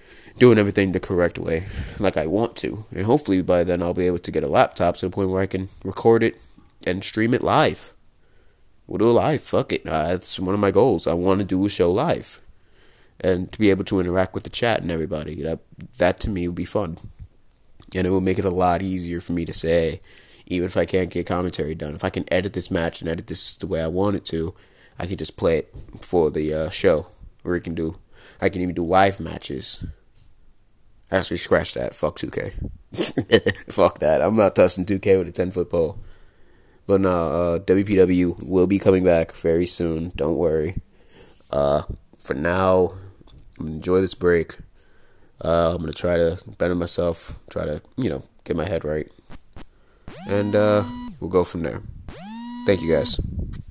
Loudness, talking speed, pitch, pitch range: -21 LUFS, 205 wpm, 90 Hz, 85-95 Hz